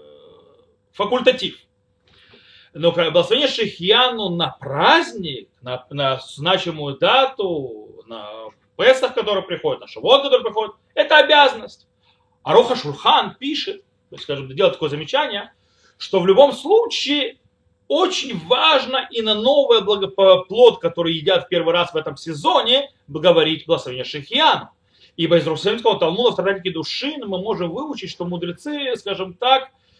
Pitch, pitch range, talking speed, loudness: 220 Hz, 170-285 Hz, 130 wpm, -18 LUFS